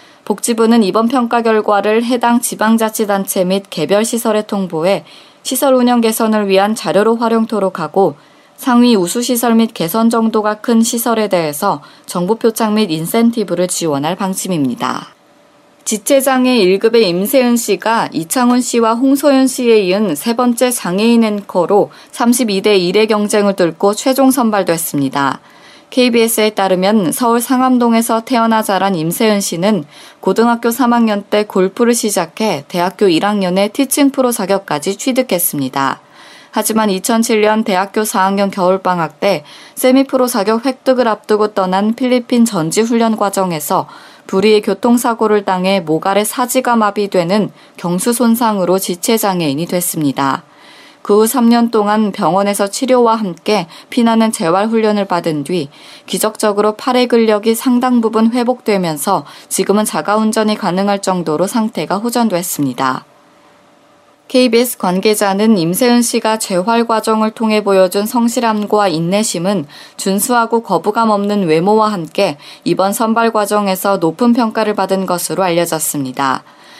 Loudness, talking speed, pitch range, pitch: -13 LUFS, 310 characters per minute, 190-235 Hz, 215 Hz